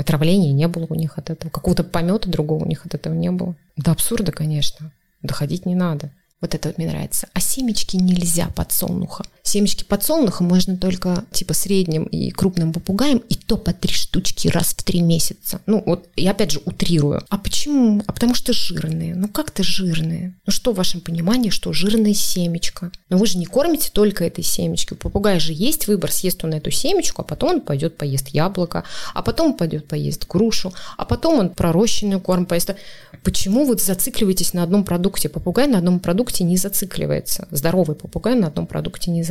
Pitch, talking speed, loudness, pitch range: 180 Hz, 190 wpm, -20 LUFS, 165-205 Hz